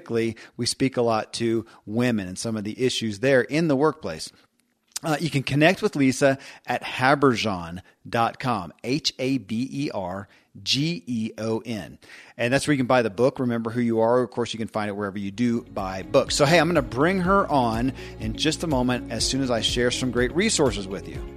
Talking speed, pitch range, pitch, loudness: 215 wpm, 110-135 Hz, 120 Hz, -24 LUFS